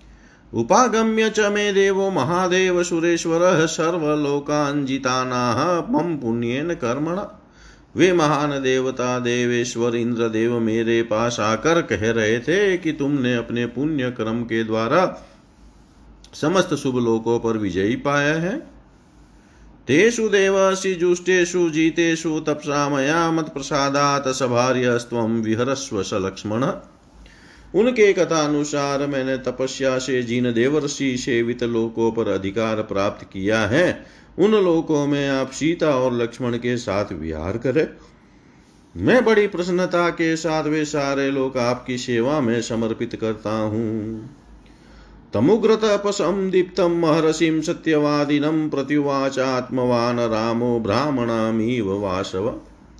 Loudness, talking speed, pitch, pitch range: -20 LUFS, 105 wpm, 135 Hz, 115-165 Hz